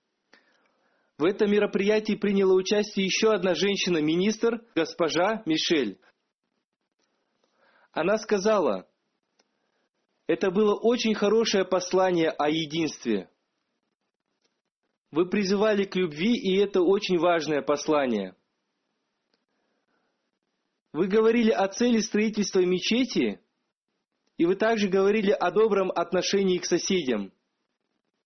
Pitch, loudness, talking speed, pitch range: 200 Hz, -25 LUFS, 90 wpm, 180-215 Hz